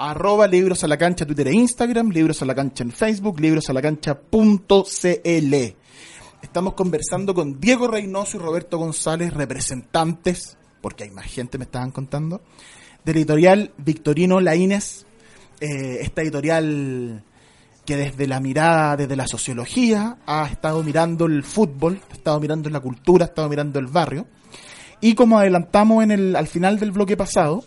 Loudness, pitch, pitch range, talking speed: -19 LUFS, 160 Hz, 145-195 Hz, 145 wpm